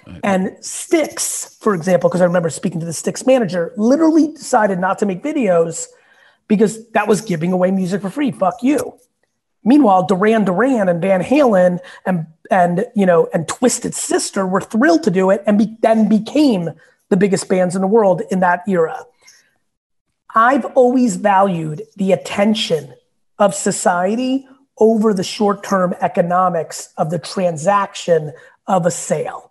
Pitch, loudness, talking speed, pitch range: 195 Hz, -16 LUFS, 155 wpm, 180-230 Hz